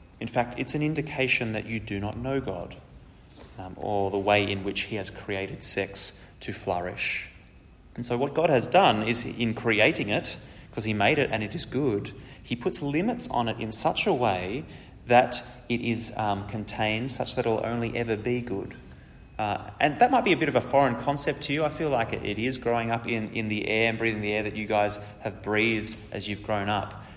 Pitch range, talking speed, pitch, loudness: 100-120 Hz, 220 wpm, 110 Hz, -27 LUFS